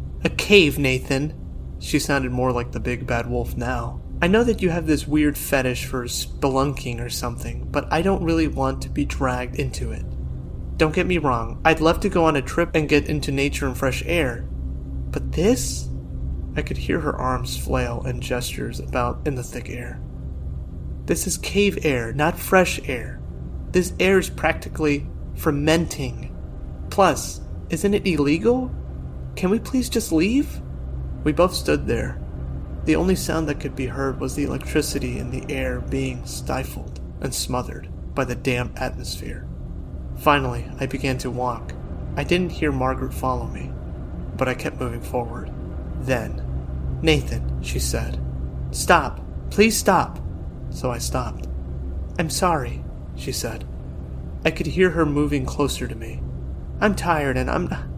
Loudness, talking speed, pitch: -23 LUFS, 160 wpm, 85 Hz